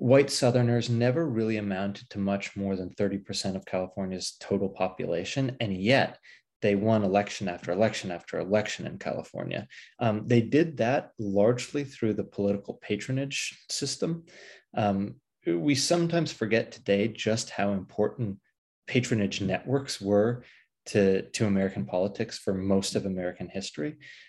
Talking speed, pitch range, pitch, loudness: 135 wpm, 100-120 Hz, 105 Hz, -28 LUFS